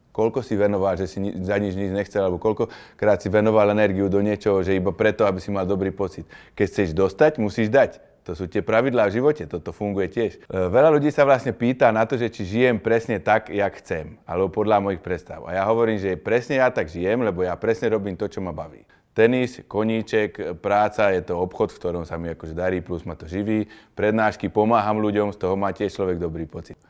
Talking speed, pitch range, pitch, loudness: 220 wpm, 95-110 Hz, 100 Hz, -22 LUFS